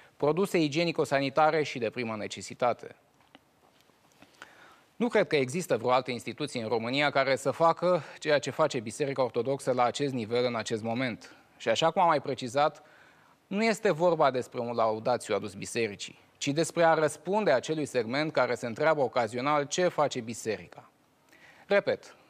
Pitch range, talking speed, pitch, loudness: 125-160 Hz, 155 wpm, 145 Hz, -29 LUFS